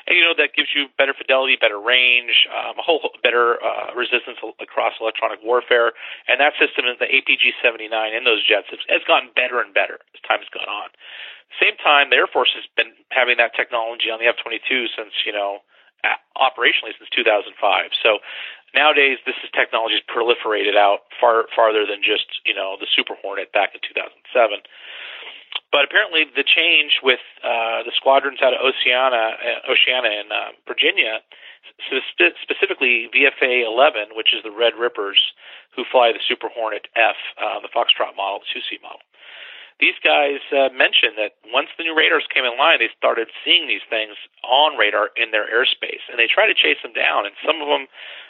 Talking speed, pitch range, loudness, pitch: 190 wpm, 115-165 Hz, -17 LUFS, 135 Hz